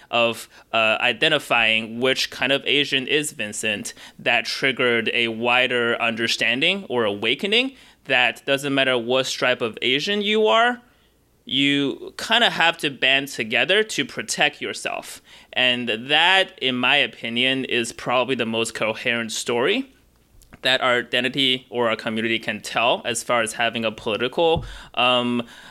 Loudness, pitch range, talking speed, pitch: -20 LUFS, 115-140 Hz, 140 wpm, 125 Hz